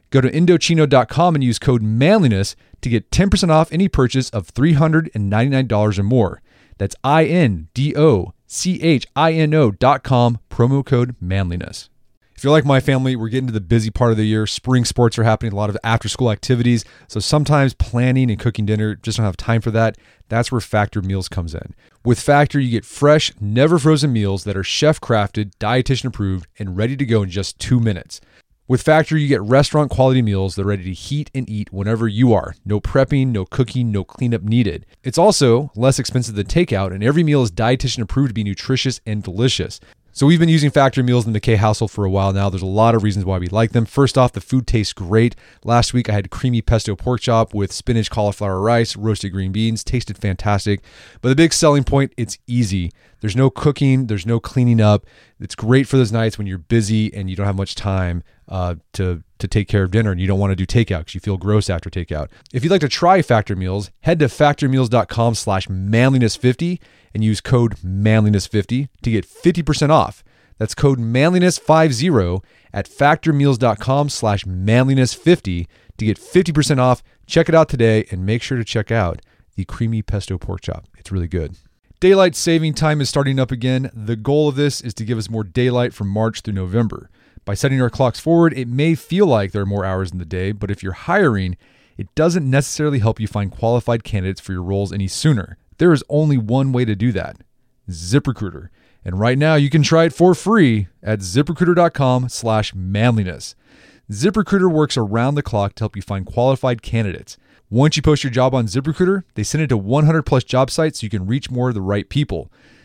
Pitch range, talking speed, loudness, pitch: 100-135 Hz, 205 wpm, -17 LUFS, 115 Hz